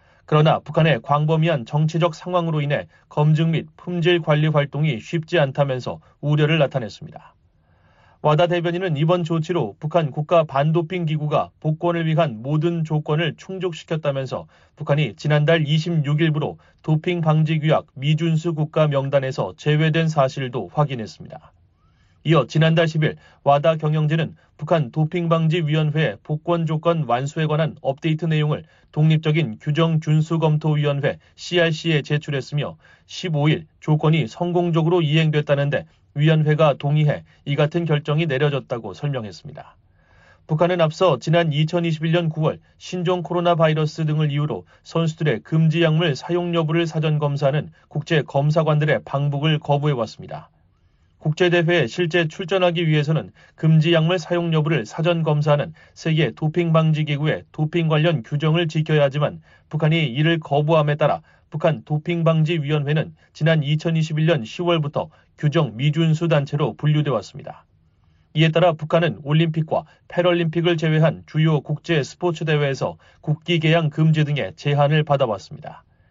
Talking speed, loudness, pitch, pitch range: 330 characters per minute, -20 LUFS, 155 Hz, 150-165 Hz